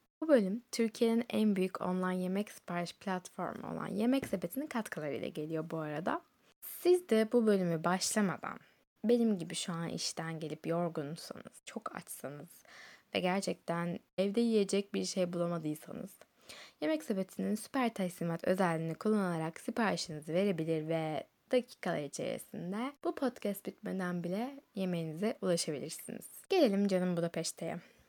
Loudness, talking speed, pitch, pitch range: -35 LUFS, 120 wpm, 190 Hz, 170-225 Hz